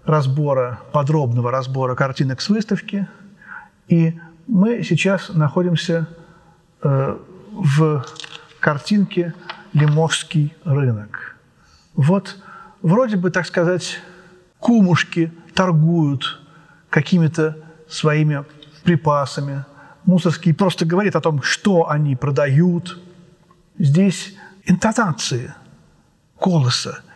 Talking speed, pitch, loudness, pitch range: 80 wpm, 165 Hz, -18 LUFS, 150-185 Hz